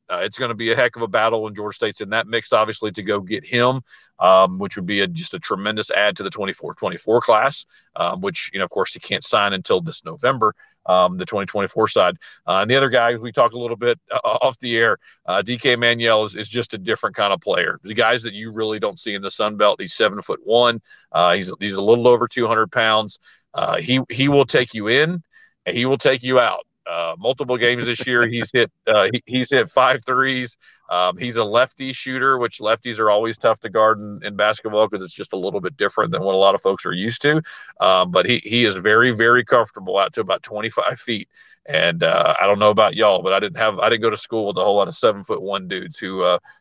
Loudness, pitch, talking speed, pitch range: -19 LUFS, 120 Hz, 255 wpm, 110-125 Hz